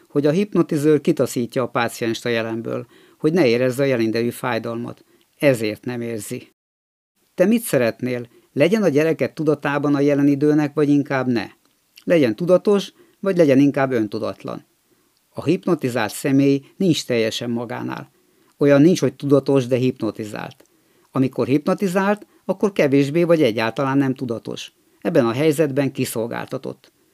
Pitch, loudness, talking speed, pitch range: 135 Hz, -19 LUFS, 135 wpm, 120-155 Hz